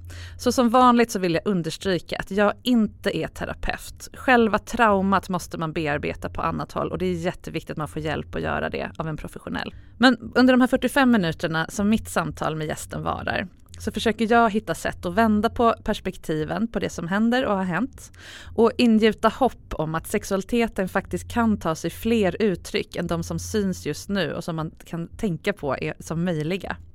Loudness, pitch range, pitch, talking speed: -23 LUFS, 160-225 Hz, 195 Hz, 200 wpm